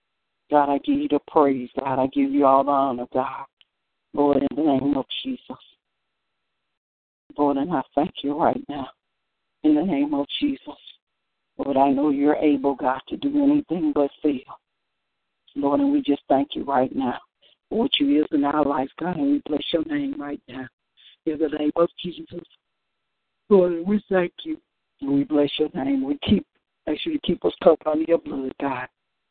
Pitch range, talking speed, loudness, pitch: 140-175 Hz, 190 wpm, -23 LUFS, 145 Hz